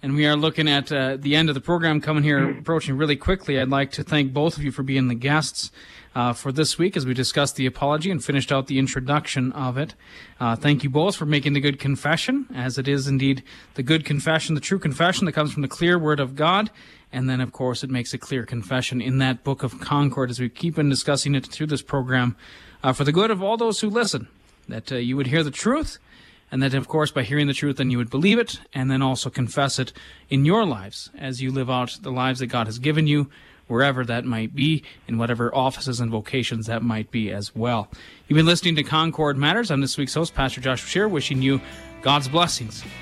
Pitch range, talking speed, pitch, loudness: 130-150 Hz, 240 wpm, 140 Hz, -22 LUFS